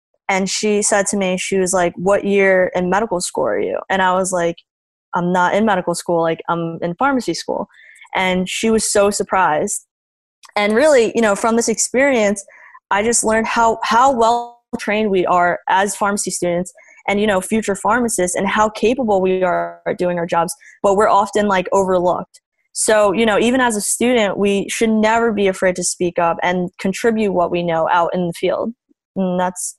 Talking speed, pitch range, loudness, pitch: 195 wpm, 180-220 Hz, -17 LUFS, 195 Hz